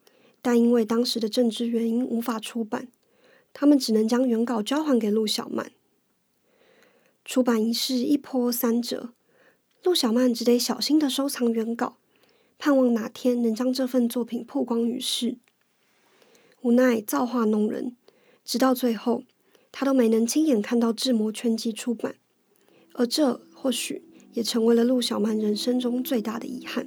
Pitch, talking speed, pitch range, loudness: 245 Hz, 230 characters per minute, 230-260 Hz, -24 LUFS